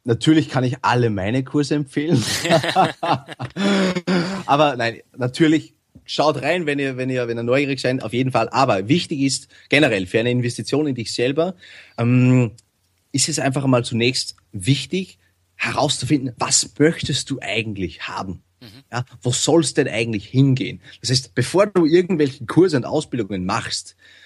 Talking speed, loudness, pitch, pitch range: 150 wpm, -20 LUFS, 130 Hz, 115-150 Hz